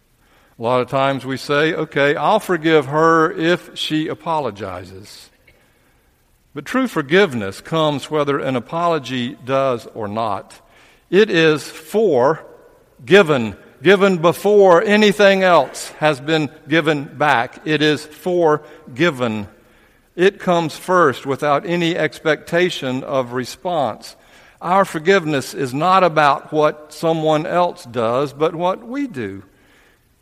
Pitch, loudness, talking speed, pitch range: 155 Hz, -17 LUFS, 120 wpm, 140-180 Hz